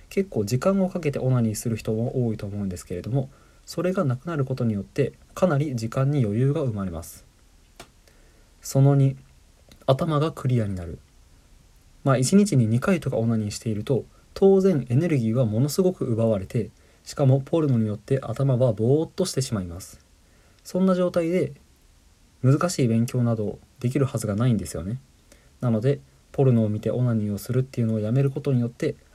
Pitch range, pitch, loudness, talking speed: 105-140 Hz, 125 Hz, -24 LUFS, 365 characters per minute